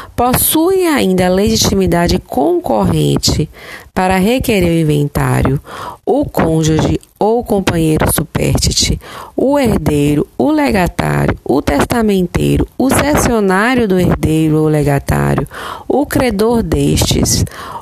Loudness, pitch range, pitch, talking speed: -13 LUFS, 155-230 Hz, 185 Hz, 100 wpm